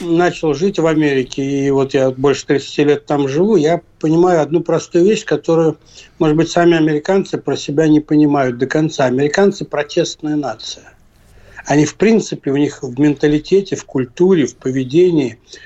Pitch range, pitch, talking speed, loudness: 140-170 Hz, 150 Hz, 160 wpm, -15 LUFS